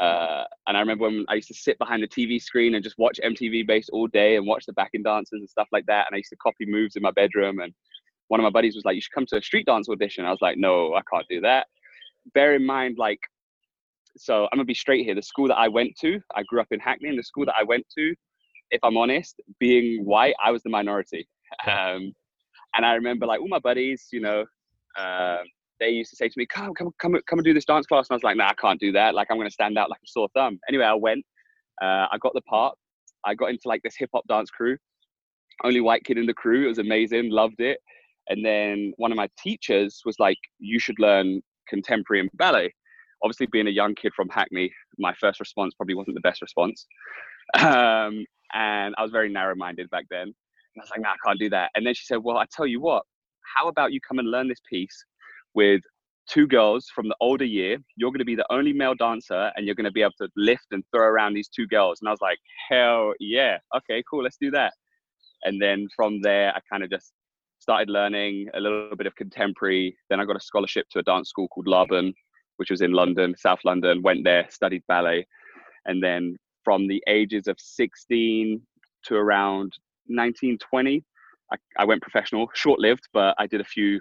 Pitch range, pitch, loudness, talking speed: 100-125 Hz, 110 Hz, -23 LUFS, 240 wpm